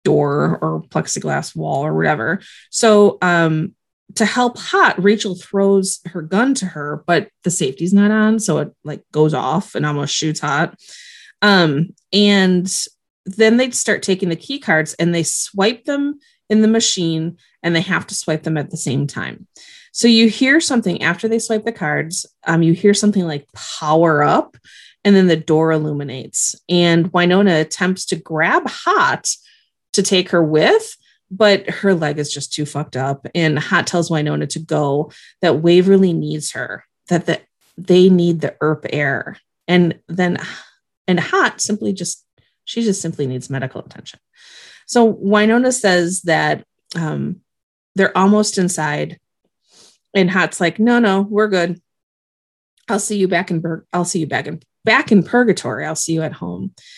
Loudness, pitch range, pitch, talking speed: -16 LUFS, 160-205 Hz, 180 Hz, 165 wpm